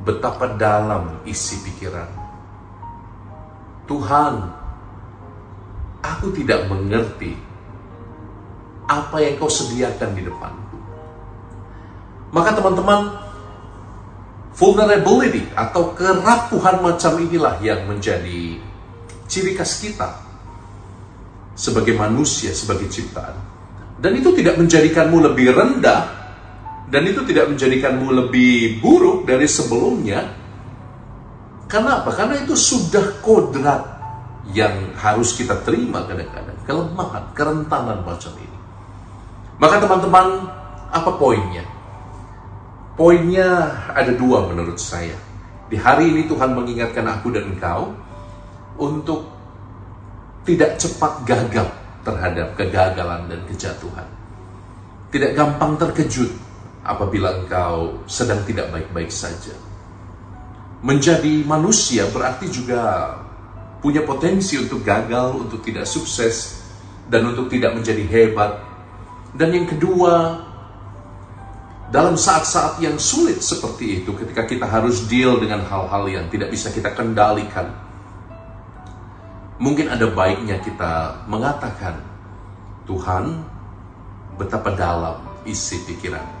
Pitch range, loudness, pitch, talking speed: 100-130 Hz, -18 LUFS, 105 Hz, 95 wpm